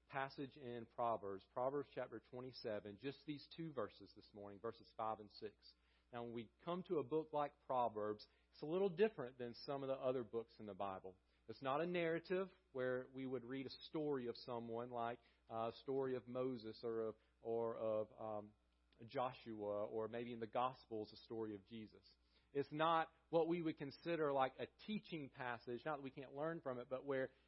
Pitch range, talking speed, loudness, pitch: 110-140 Hz, 195 wpm, -46 LUFS, 125 Hz